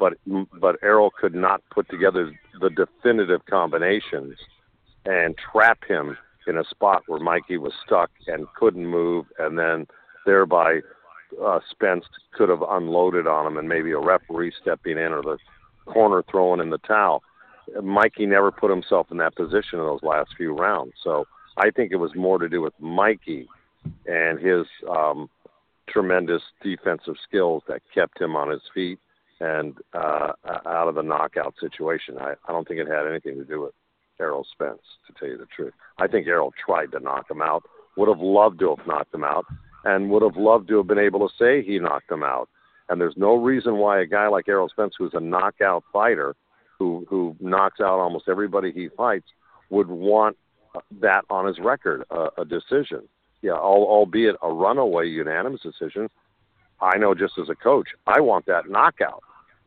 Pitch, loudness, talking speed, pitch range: 95 Hz, -22 LUFS, 180 wpm, 85-105 Hz